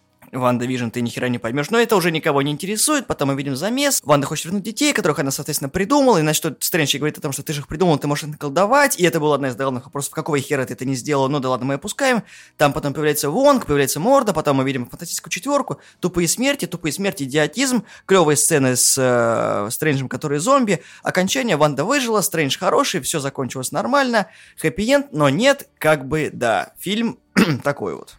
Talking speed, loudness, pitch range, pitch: 205 wpm, -19 LUFS, 140-205 Hz, 155 Hz